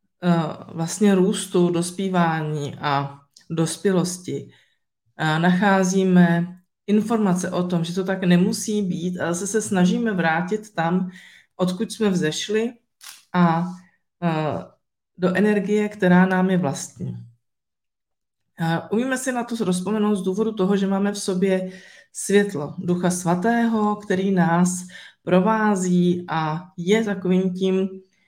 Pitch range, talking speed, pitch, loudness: 170-205 Hz, 110 wpm, 185 Hz, -21 LUFS